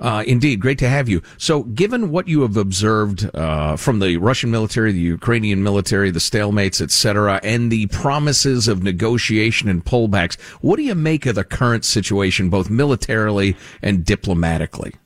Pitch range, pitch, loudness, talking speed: 95-125 Hz, 105 Hz, -17 LUFS, 170 wpm